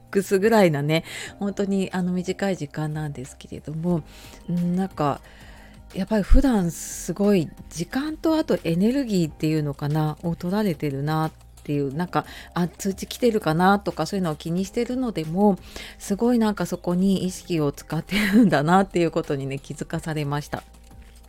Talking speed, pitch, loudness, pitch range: 350 characters per minute, 175 Hz, -24 LUFS, 155-195 Hz